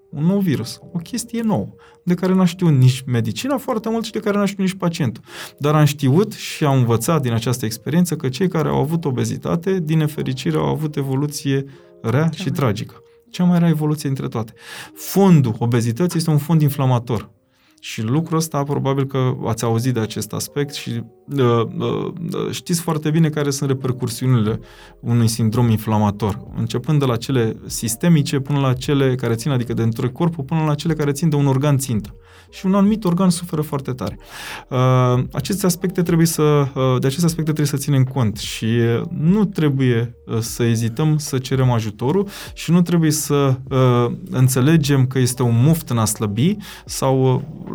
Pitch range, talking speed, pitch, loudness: 120-165 Hz, 185 wpm, 140 Hz, -19 LUFS